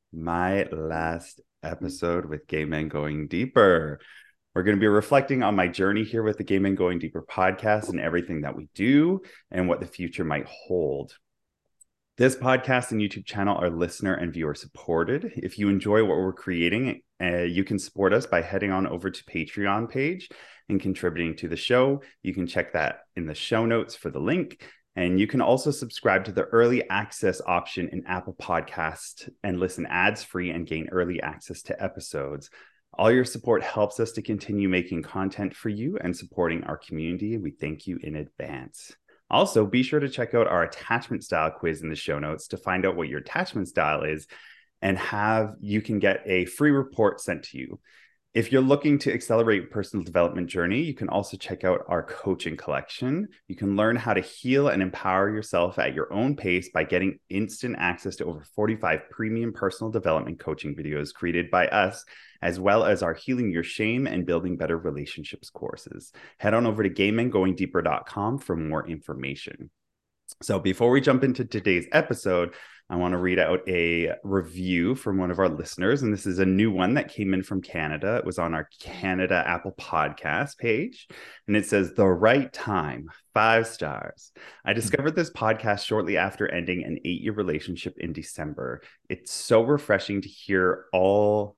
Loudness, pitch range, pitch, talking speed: -26 LUFS, 85-110 Hz, 95 Hz, 185 wpm